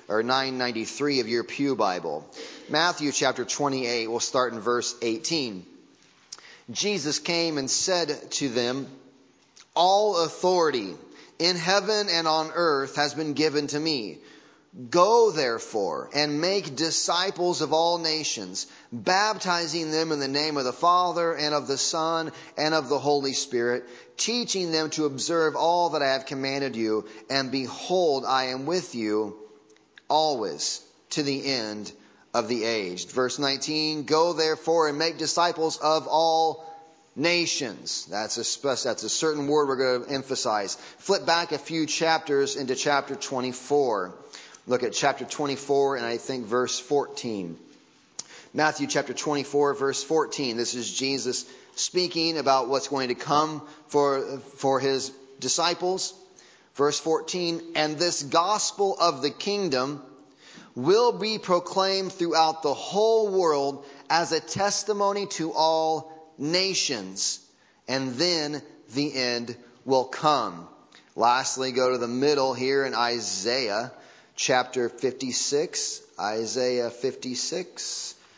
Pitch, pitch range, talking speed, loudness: 145 Hz, 130-165 Hz, 135 wpm, -25 LUFS